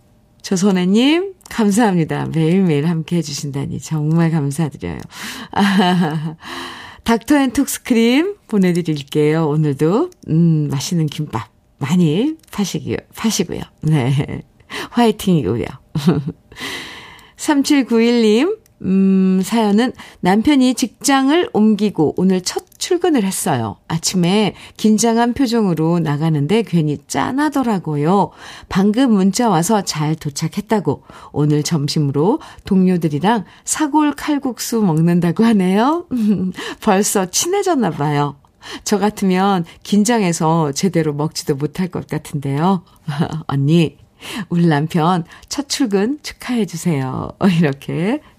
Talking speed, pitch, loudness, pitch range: 245 characters per minute, 185 Hz, -17 LUFS, 155-225 Hz